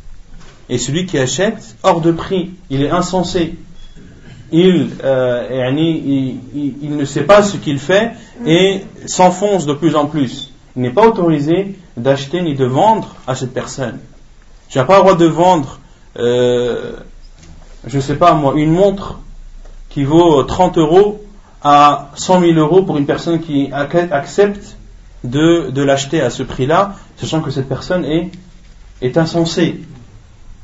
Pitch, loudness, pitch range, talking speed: 155 Hz, -14 LUFS, 130-175 Hz, 155 wpm